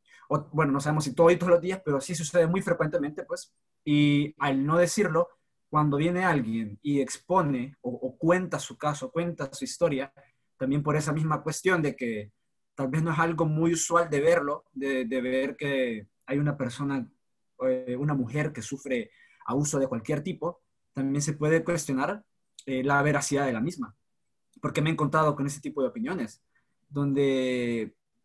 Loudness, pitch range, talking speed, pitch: -28 LUFS, 135-165 Hz, 180 wpm, 145 Hz